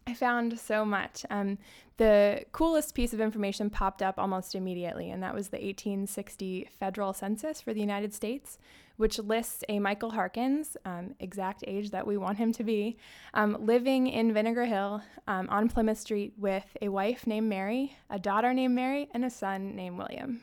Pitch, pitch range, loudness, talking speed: 210 Hz, 195-235 Hz, -31 LUFS, 180 wpm